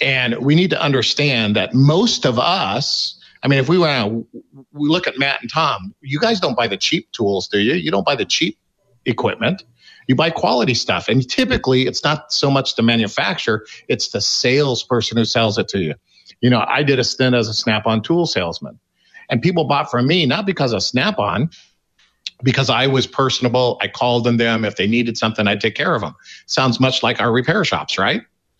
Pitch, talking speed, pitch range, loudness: 130 Hz, 205 wpm, 115-145 Hz, -17 LUFS